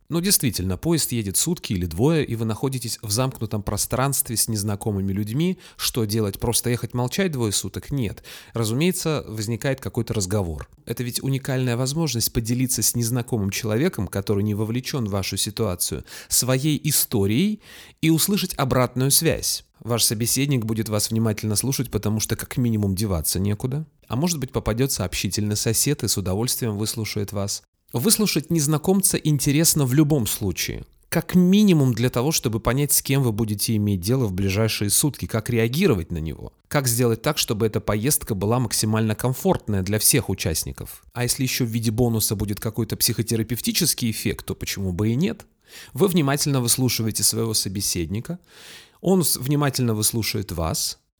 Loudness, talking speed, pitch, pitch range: -22 LUFS, 155 wpm, 115 Hz, 105-140 Hz